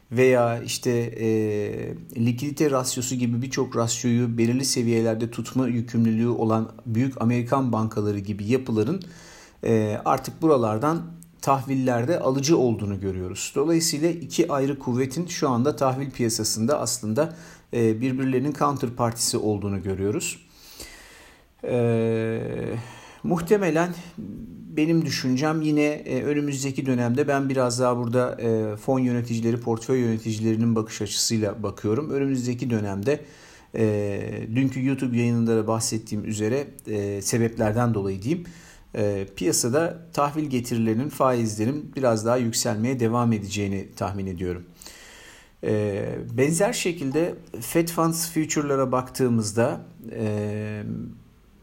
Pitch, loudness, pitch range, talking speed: 120 Hz, -24 LUFS, 110-140 Hz, 100 wpm